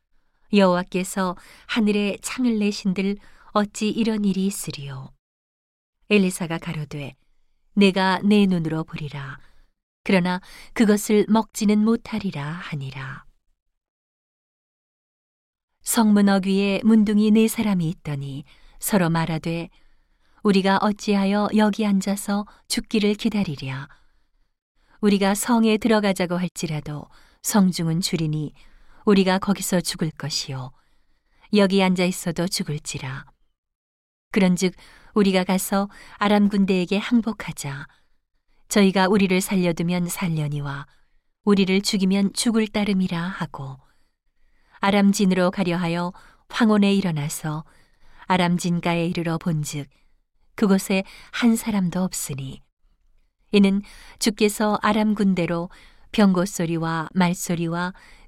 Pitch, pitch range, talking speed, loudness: 190 Hz, 165-205 Hz, 245 characters per minute, -22 LUFS